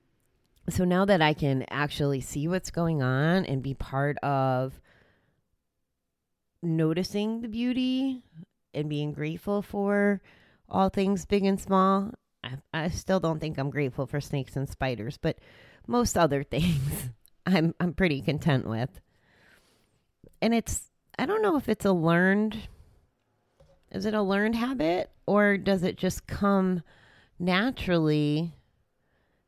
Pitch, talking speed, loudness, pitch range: 165 Hz, 135 wpm, -27 LUFS, 140-200 Hz